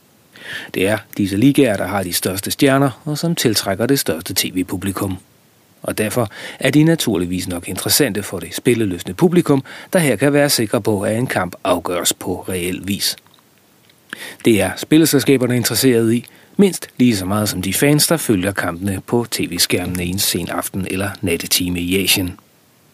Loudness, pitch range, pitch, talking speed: -17 LUFS, 95-140 Hz, 110 Hz, 165 wpm